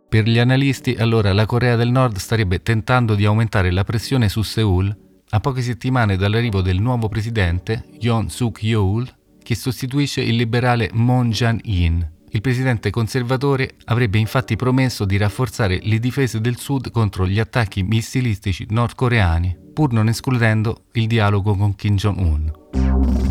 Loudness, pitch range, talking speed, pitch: -19 LUFS, 100-125 Hz, 150 wpm, 115 Hz